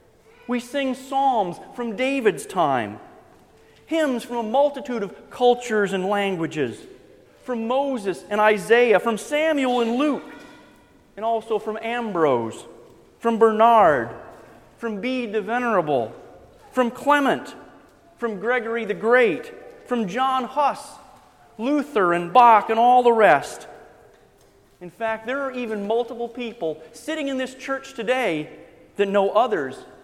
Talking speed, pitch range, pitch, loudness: 125 wpm, 215-265 Hz, 235 Hz, -21 LUFS